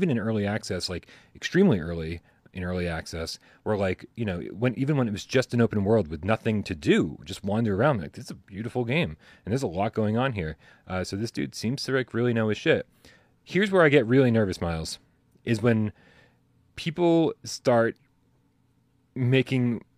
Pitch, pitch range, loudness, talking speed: 115 Hz, 95-125 Hz, -26 LUFS, 200 wpm